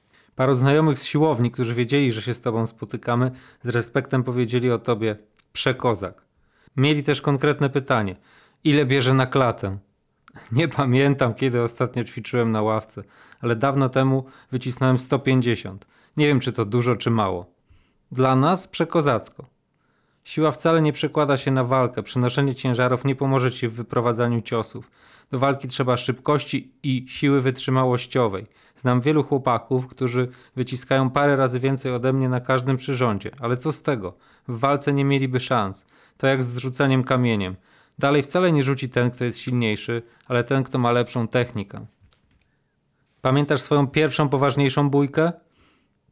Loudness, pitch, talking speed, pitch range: -22 LUFS, 130 Hz, 150 wpm, 120-140 Hz